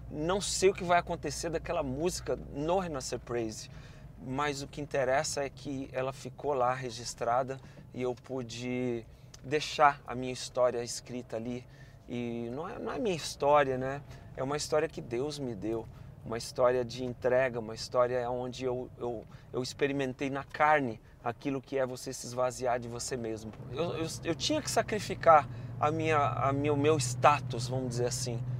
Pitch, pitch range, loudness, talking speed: 130 Hz, 125-145 Hz, -32 LUFS, 170 wpm